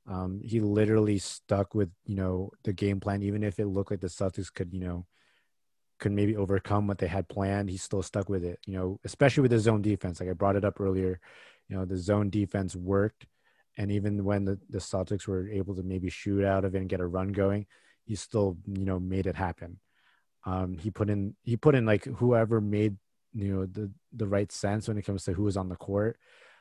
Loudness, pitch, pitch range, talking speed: -30 LUFS, 100 Hz, 95-105 Hz, 230 wpm